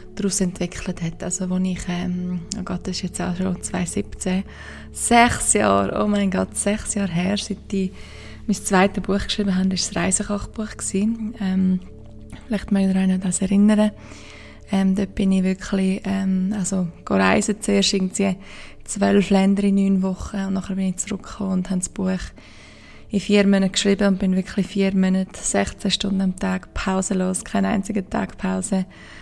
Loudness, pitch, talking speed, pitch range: -21 LUFS, 190 Hz, 165 wpm, 185-200 Hz